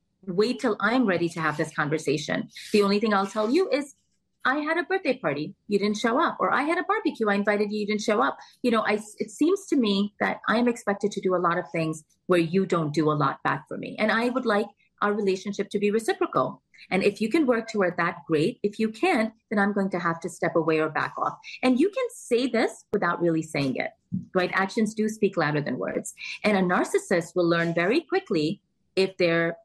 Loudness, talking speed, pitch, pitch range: -25 LUFS, 235 wpm, 205 Hz, 175-235 Hz